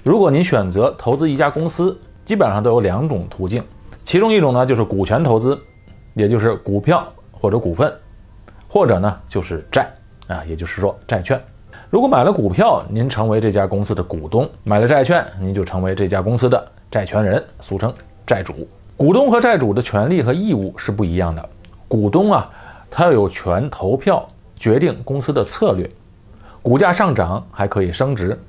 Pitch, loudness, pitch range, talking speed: 105 Hz, -17 LUFS, 95-120 Hz, 275 characters per minute